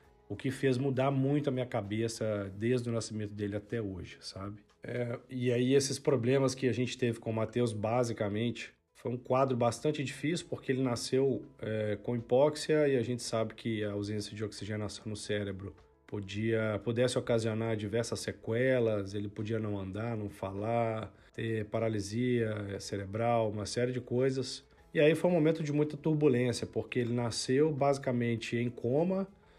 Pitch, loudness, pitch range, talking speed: 115 Hz, -33 LUFS, 110-130 Hz, 165 wpm